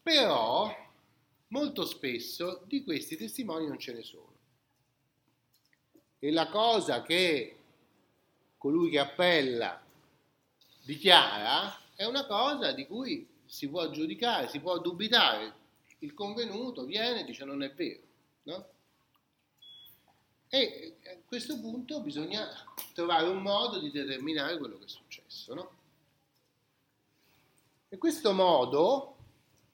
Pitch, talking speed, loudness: 175 Hz, 115 wpm, -30 LUFS